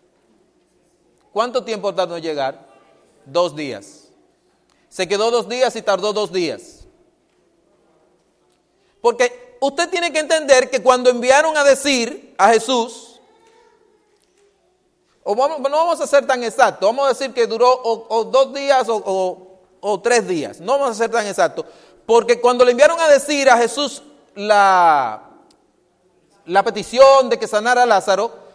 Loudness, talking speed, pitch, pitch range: -16 LUFS, 150 wpm, 245 Hz, 210-285 Hz